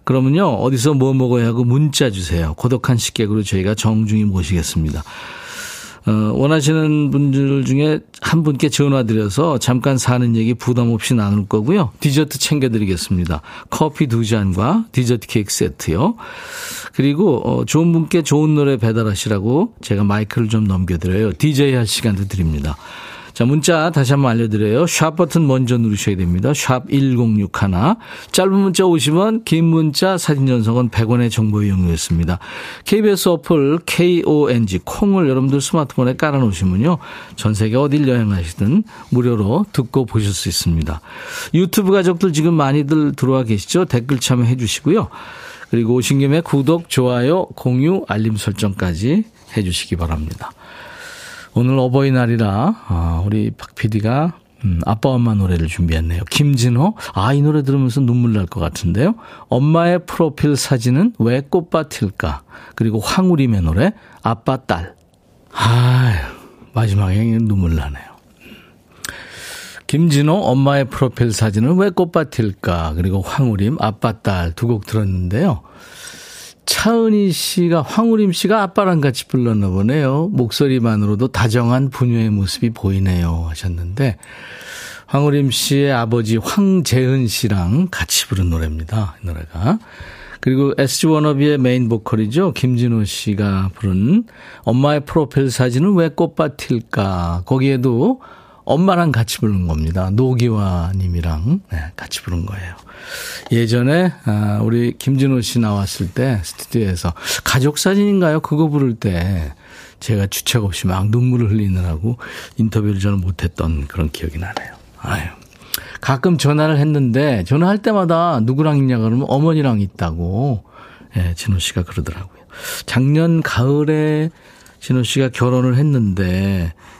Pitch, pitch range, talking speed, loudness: 125 Hz, 105-150 Hz, 310 characters per minute, -16 LUFS